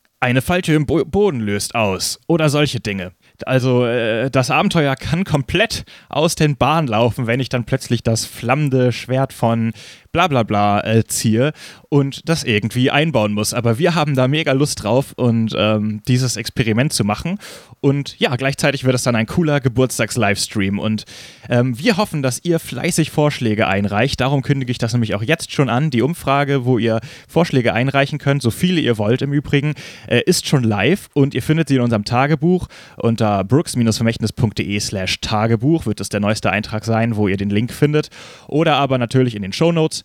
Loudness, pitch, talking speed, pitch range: -17 LUFS, 125 Hz, 180 wpm, 110-145 Hz